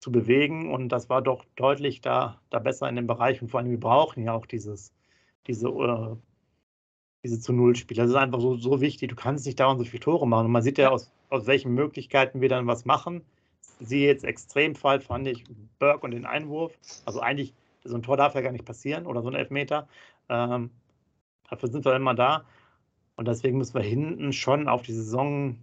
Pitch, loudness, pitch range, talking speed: 125 Hz, -26 LUFS, 120-140 Hz, 215 wpm